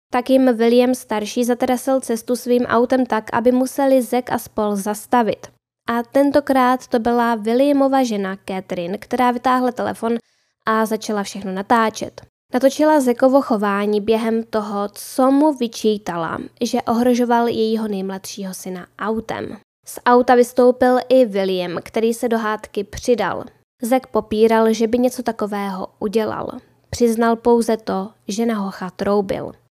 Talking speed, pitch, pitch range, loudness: 135 wpm, 235 Hz, 210-250 Hz, -18 LUFS